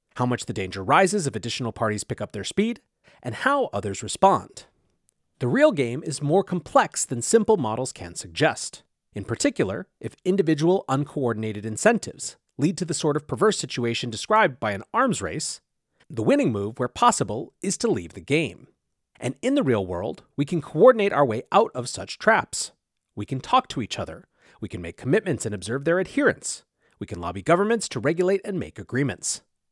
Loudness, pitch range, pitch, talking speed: -24 LUFS, 115-185 Hz, 140 Hz, 185 wpm